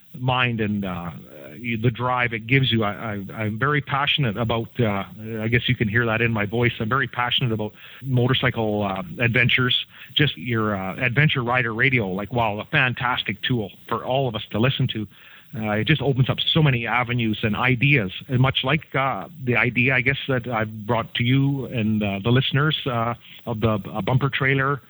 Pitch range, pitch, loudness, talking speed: 110-130 Hz, 120 Hz, -22 LUFS, 200 wpm